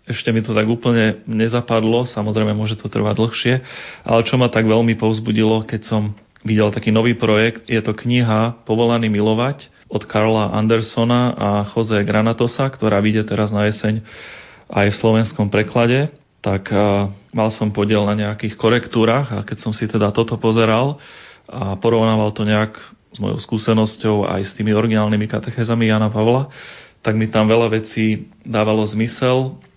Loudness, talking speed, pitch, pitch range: -18 LUFS, 155 wpm, 110 Hz, 105-115 Hz